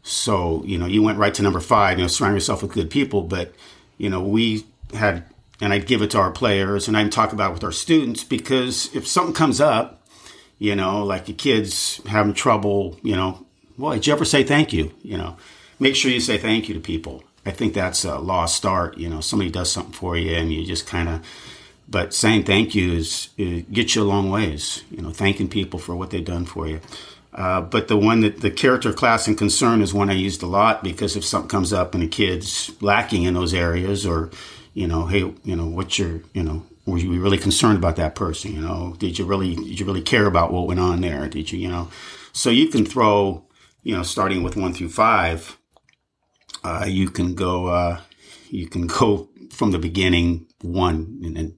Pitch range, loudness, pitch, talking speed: 85-105 Hz, -21 LUFS, 95 Hz, 225 wpm